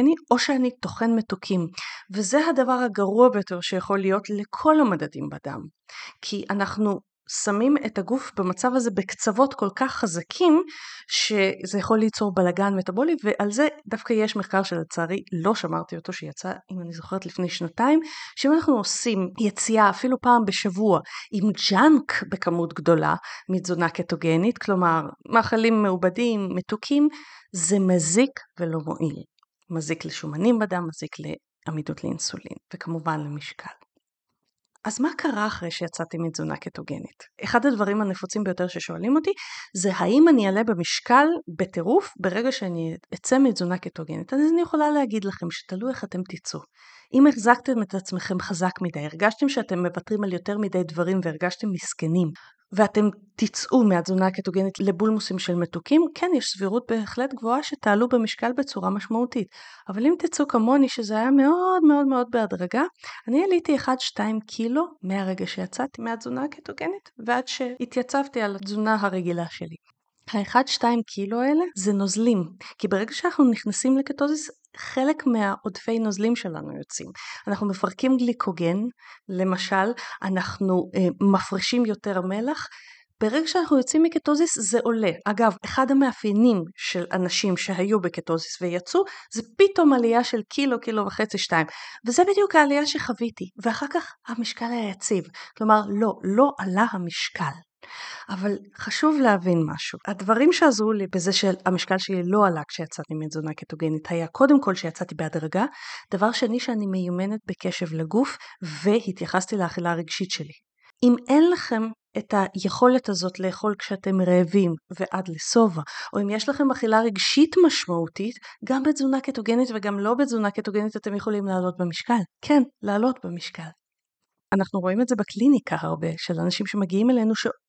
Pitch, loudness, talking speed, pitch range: 210 Hz, -23 LUFS, 140 wpm, 185-250 Hz